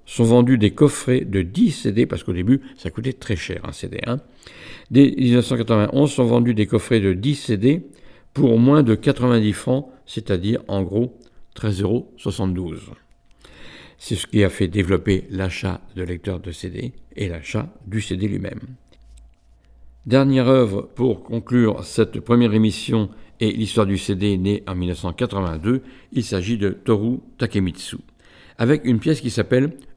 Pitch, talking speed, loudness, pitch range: 110 Hz, 150 wpm, -20 LUFS, 95-125 Hz